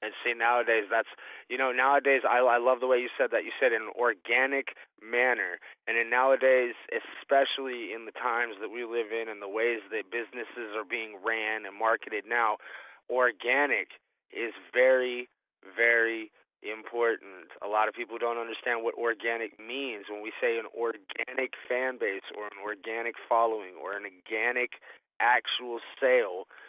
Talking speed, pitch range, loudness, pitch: 160 wpm, 115-130 Hz, -29 LUFS, 120 Hz